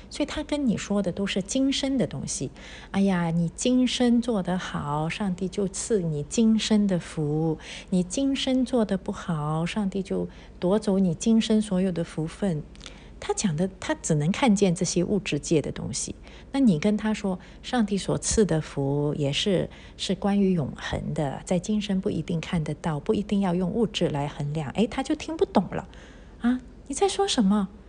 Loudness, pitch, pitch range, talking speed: -26 LUFS, 195 Hz, 170-225 Hz, 255 characters per minute